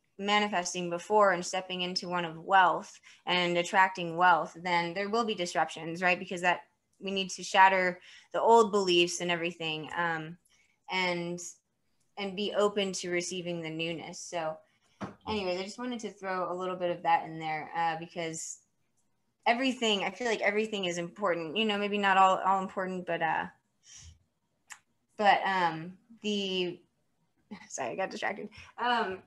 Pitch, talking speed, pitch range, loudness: 180 Hz, 160 wpm, 170-195 Hz, -30 LUFS